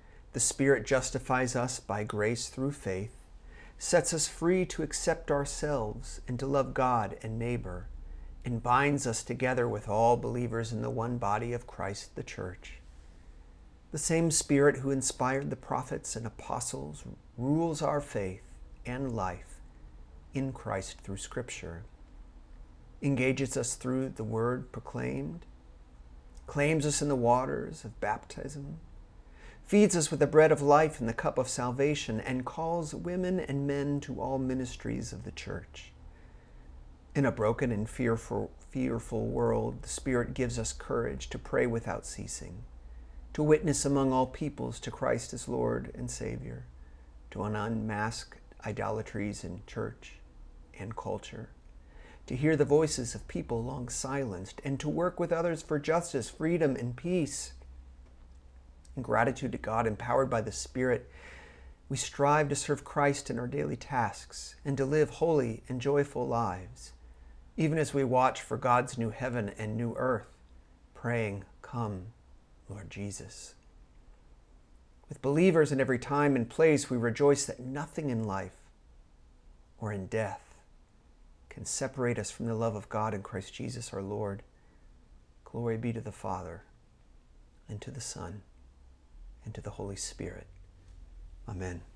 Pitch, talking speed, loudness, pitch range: 115 Hz, 145 wpm, -32 LUFS, 80-135 Hz